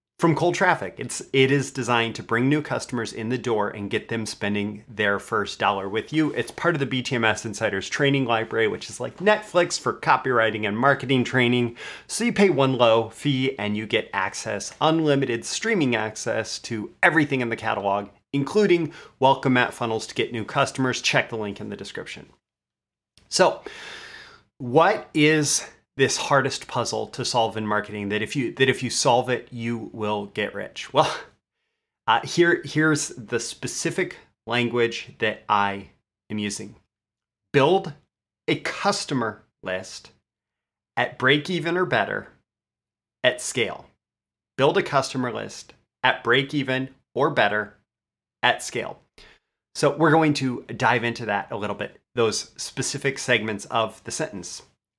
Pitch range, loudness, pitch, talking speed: 110-150 Hz, -23 LUFS, 125 Hz, 155 wpm